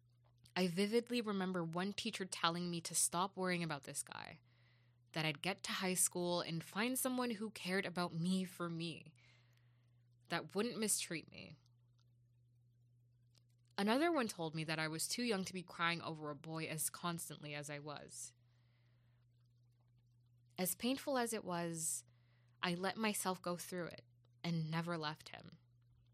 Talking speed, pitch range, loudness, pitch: 155 wpm, 120-185 Hz, -40 LUFS, 165 Hz